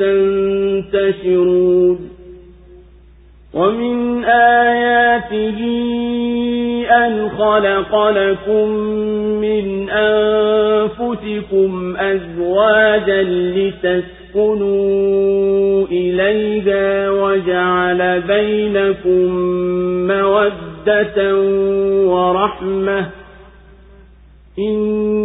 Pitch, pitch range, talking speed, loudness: 195 Hz, 180-215 Hz, 35 wpm, -15 LUFS